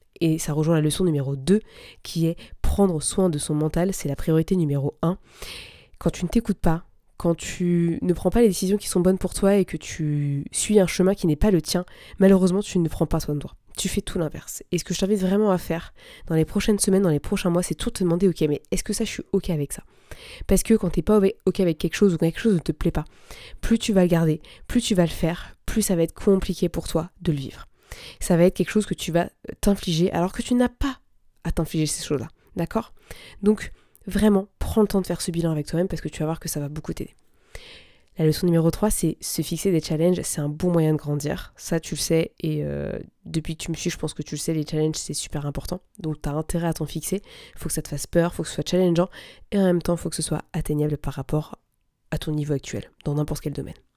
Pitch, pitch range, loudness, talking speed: 170 Hz, 155-195 Hz, -24 LUFS, 270 wpm